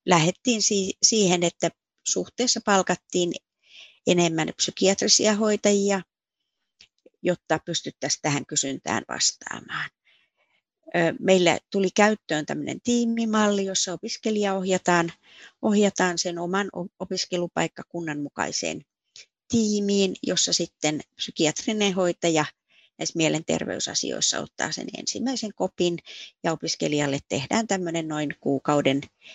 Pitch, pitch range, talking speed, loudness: 180 Hz, 165-205 Hz, 90 wpm, -24 LUFS